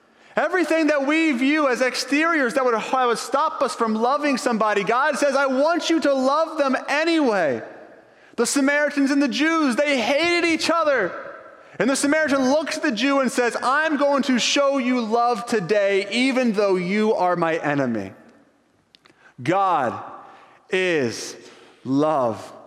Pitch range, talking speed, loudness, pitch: 235-300 Hz, 150 wpm, -20 LUFS, 275 Hz